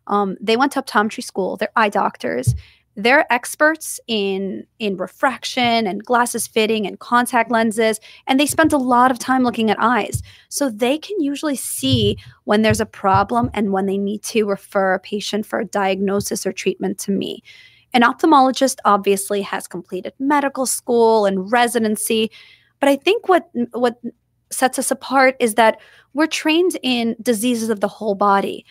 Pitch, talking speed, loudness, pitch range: 230 Hz, 170 wpm, -18 LUFS, 205-260 Hz